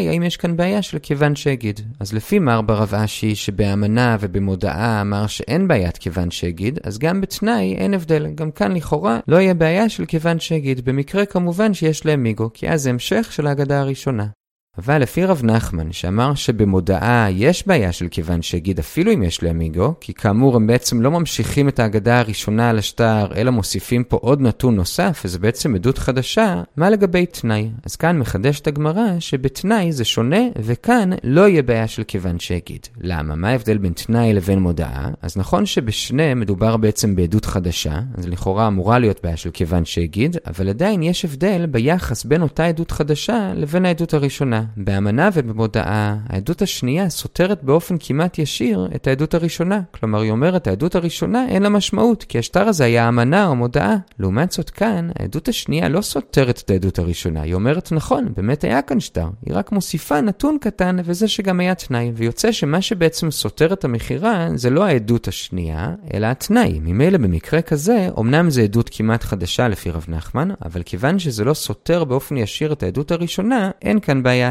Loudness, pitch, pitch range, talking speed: -18 LUFS, 125 Hz, 105-170 Hz, 175 wpm